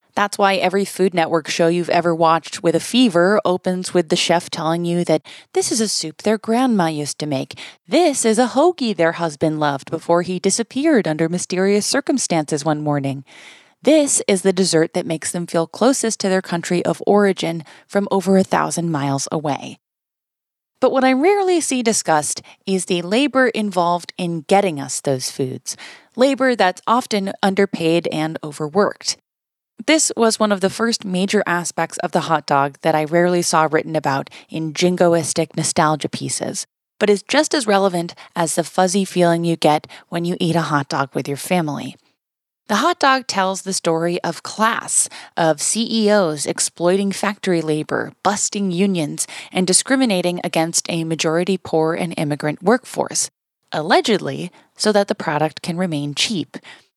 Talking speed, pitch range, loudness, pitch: 165 wpm, 160-205 Hz, -18 LUFS, 180 Hz